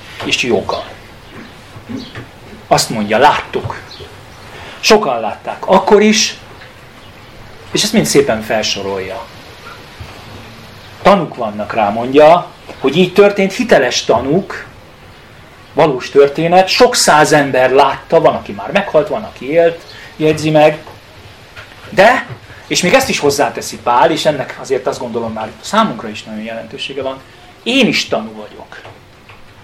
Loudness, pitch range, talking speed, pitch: -12 LUFS, 110-165 Hz, 120 wpm, 130 Hz